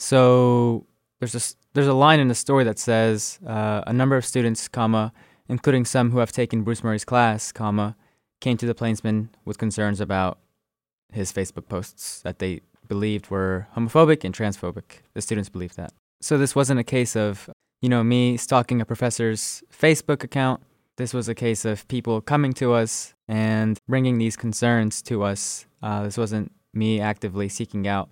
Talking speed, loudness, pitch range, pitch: 175 wpm, -23 LUFS, 105-125 Hz, 115 Hz